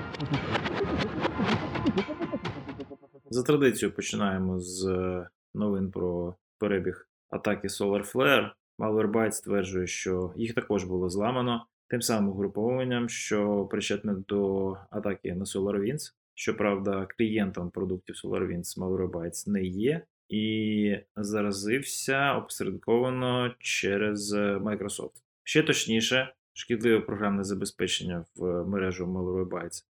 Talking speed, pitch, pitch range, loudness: 90 wpm, 100 Hz, 95-115 Hz, -29 LUFS